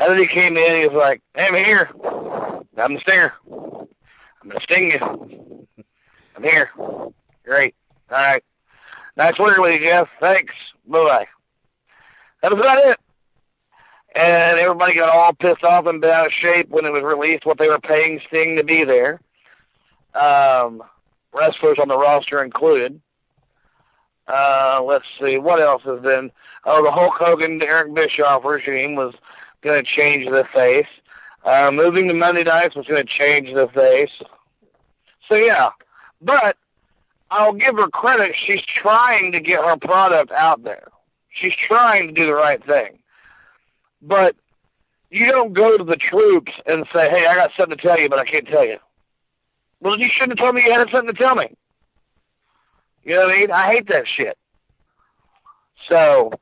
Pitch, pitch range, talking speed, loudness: 170 Hz, 150-215 Hz, 170 wpm, -15 LUFS